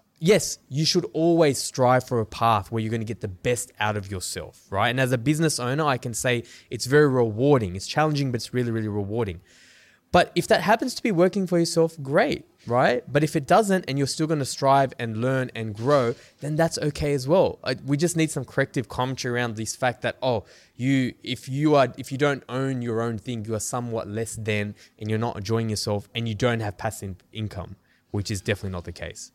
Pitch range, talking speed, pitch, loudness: 110-145 Hz, 225 wpm, 125 Hz, -24 LUFS